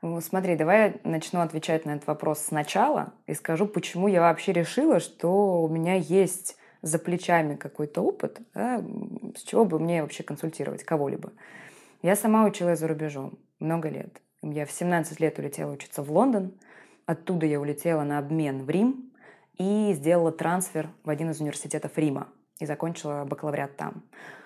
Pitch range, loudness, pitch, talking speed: 155-190 Hz, -27 LUFS, 165 Hz, 160 wpm